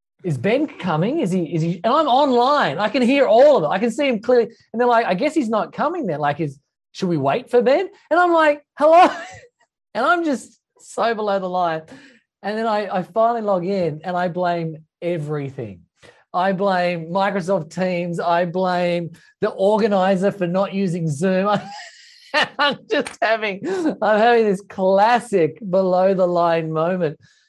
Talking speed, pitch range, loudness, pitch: 180 wpm, 175-235 Hz, -19 LUFS, 195 Hz